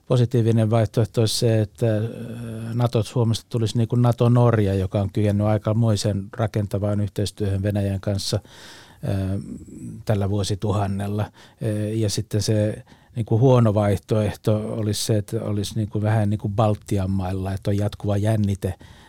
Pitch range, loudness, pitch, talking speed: 105-115 Hz, -22 LUFS, 105 Hz, 135 wpm